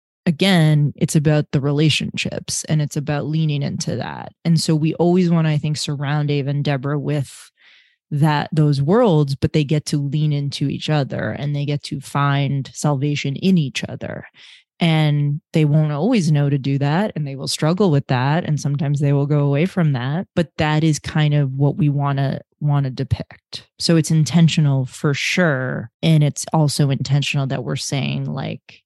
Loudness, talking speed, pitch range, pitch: -19 LUFS, 190 wpm, 140-155 Hz, 150 Hz